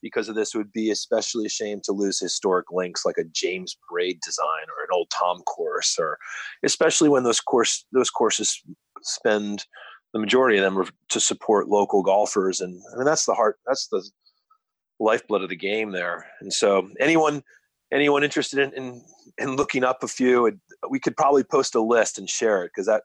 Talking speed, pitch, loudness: 200 wpm, 145 Hz, -23 LUFS